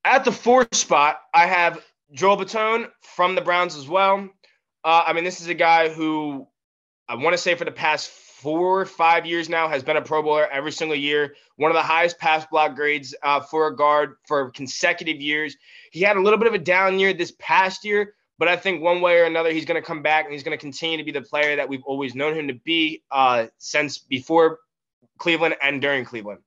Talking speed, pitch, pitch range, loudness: 230 wpm, 160 Hz, 150-180 Hz, -20 LUFS